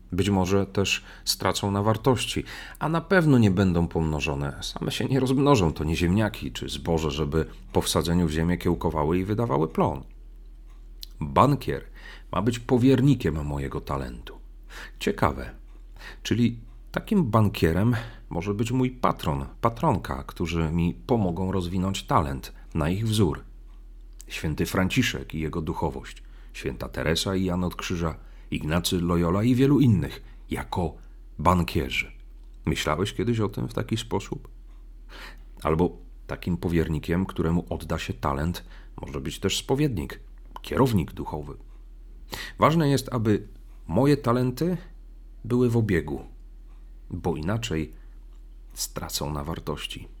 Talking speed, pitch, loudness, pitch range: 125 wpm, 90 Hz, -26 LUFS, 80-115 Hz